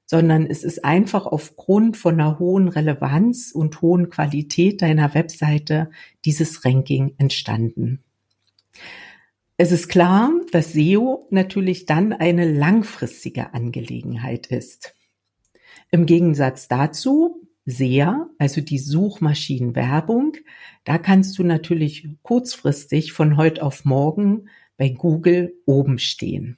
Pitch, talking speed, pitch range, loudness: 160 Hz, 110 wpm, 145-185 Hz, -19 LUFS